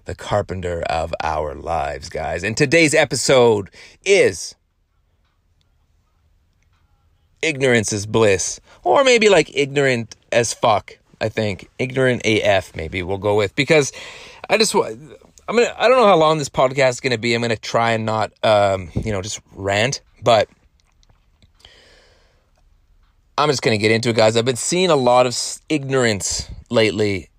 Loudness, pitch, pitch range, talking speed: -18 LUFS, 110 Hz, 90-130 Hz, 155 wpm